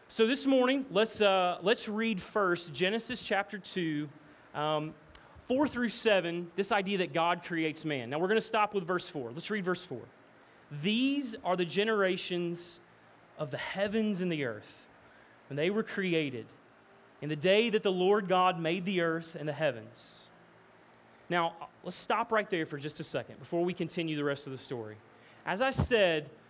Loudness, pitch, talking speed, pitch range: -31 LUFS, 180 Hz, 180 wpm, 155-210 Hz